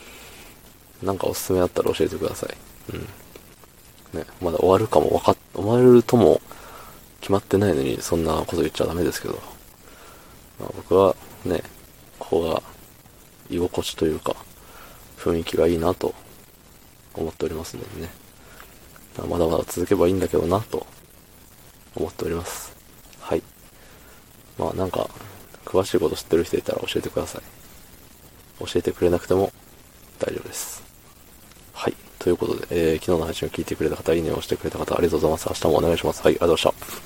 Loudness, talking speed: -23 LUFS, 360 characters per minute